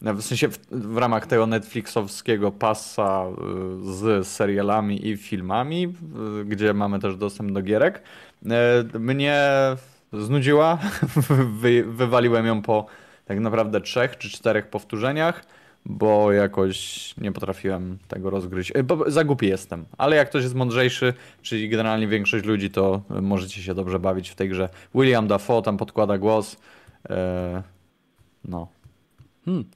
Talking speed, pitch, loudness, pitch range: 140 wpm, 110 Hz, -23 LUFS, 95-120 Hz